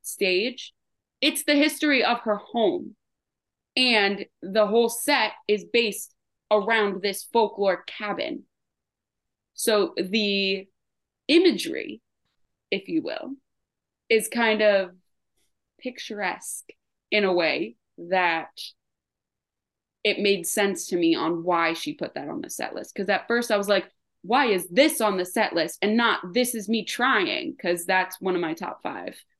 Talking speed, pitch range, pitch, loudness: 145 wpm, 195-260 Hz, 215 Hz, -24 LUFS